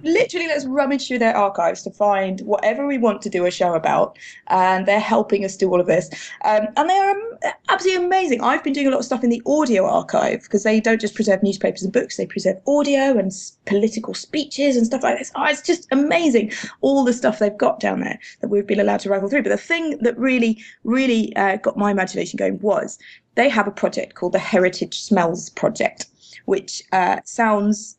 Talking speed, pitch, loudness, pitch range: 215 wpm, 225 Hz, -19 LUFS, 200-280 Hz